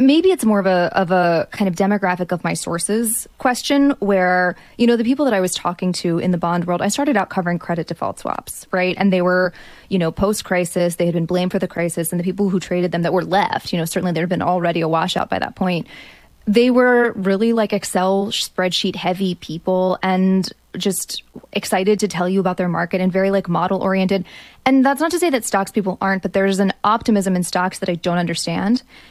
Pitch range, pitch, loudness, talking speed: 180-205 Hz, 190 Hz, -18 LUFS, 230 wpm